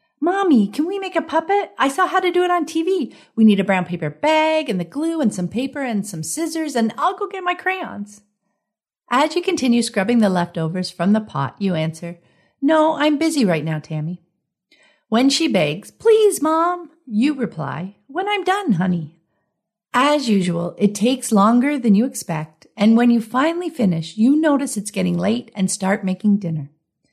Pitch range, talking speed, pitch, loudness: 185-315 Hz, 190 wpm, 225 Hz, -19 LUFS